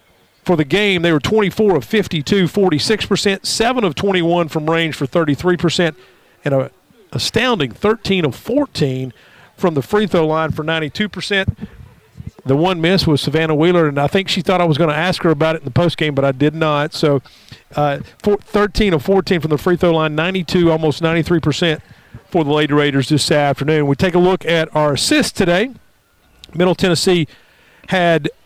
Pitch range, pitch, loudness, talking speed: 150-185 Hz, 165 Hz, -16 LUFS, 180 wpm